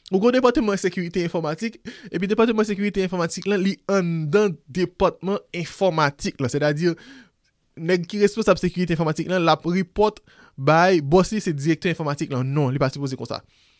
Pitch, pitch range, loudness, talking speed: 180 Hz, 155-195 Hz, -22 LUFS, 180 wpm